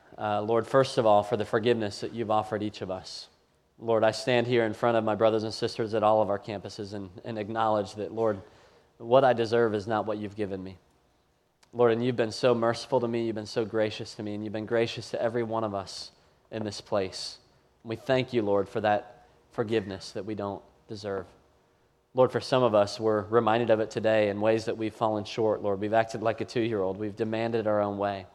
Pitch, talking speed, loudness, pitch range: 110 Hz, 235 wpm, -28 LUFS, 105-115 Hz